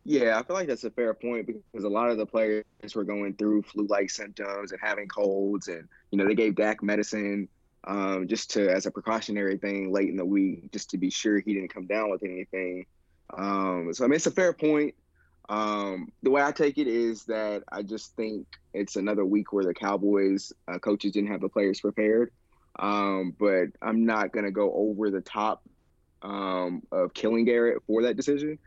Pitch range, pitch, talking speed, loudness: 95-110 Hz, 105 Hz, 210 wpm, -28 LUFS